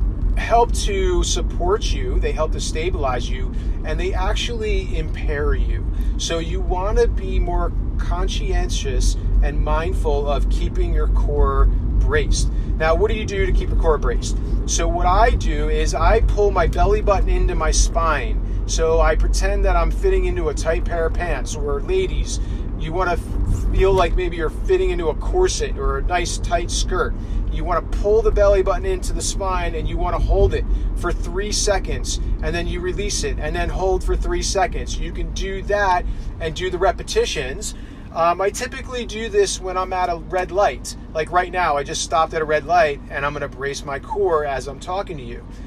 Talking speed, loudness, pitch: 200 wpm, -21 LUFS, 195 Hz